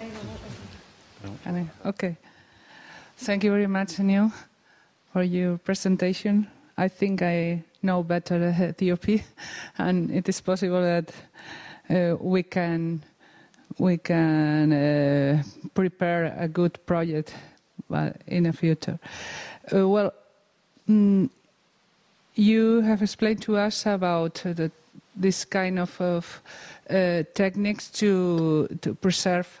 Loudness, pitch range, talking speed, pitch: -25 LUFS, 170-200 Hz, 105 wpm, 180 Hz